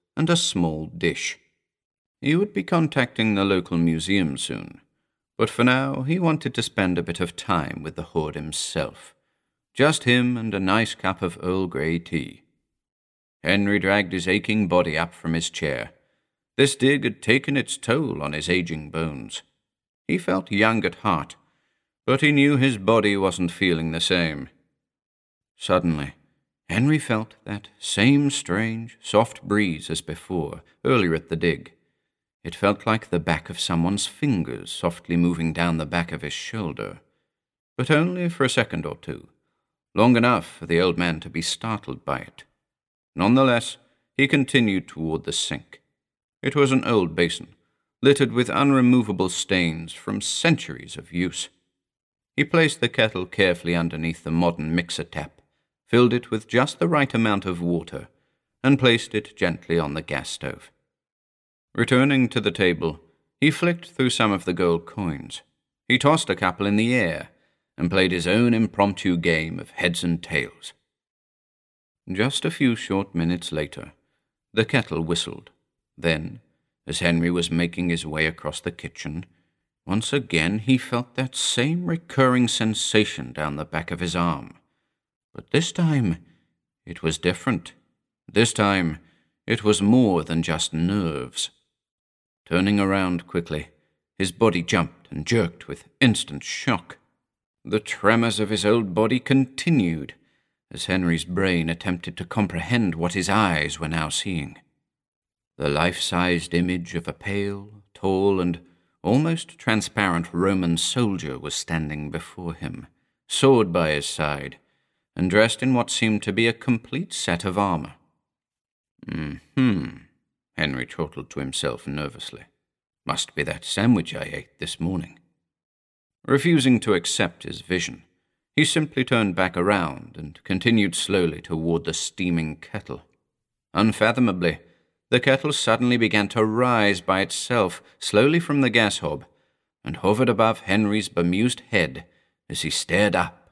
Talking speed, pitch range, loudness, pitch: 150 wpm, 85-120 Hz, -23 LUFS, 95 Hz